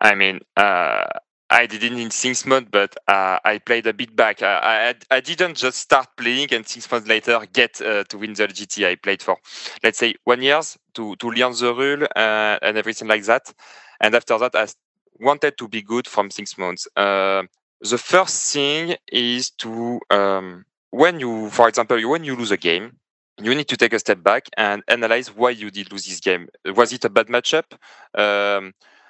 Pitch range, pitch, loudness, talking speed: 105-125 Hz, 115 Hz, -19 LUFS, 200 wpm